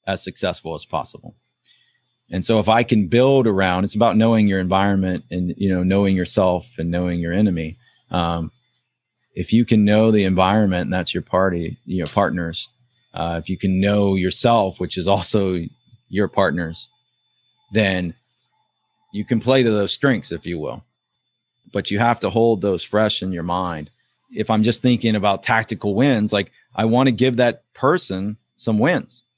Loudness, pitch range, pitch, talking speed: -19 LUFS, 95-115 Hz, 105 Hz, 175 wpm